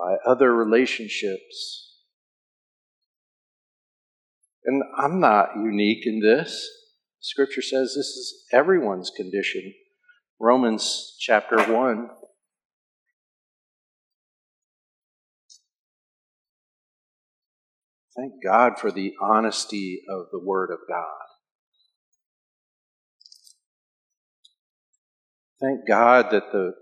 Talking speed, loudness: 70 wpm, -22 LUFS